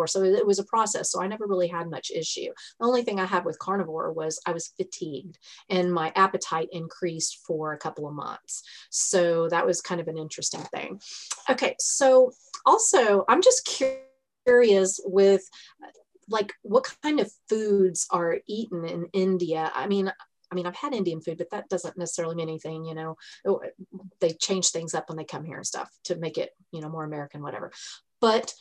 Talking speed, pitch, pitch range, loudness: 190 wpm, 185 Hz, 165-215 Hz, -26 LUFS